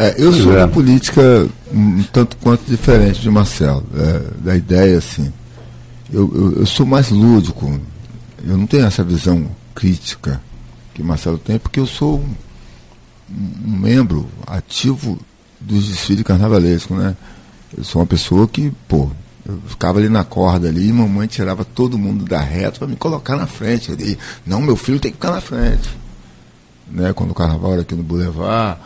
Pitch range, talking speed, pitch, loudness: 85-120 Hz, 170 wpm, 100 Hz, -15 LUFS